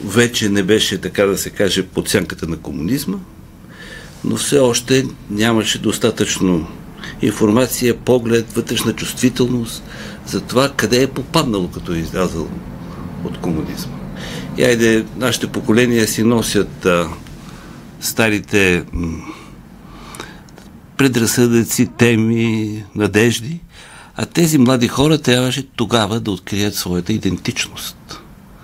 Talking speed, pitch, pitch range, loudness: 110 wpm, 115 Hz, 100-125 Hz, -16 LUFS